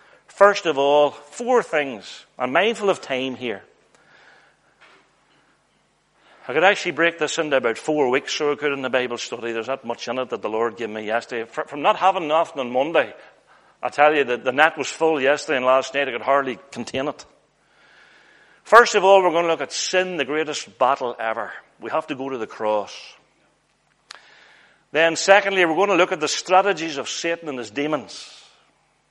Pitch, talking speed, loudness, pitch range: 150 Hz, 195 wpm, -20 LUFS, 130-170 Hz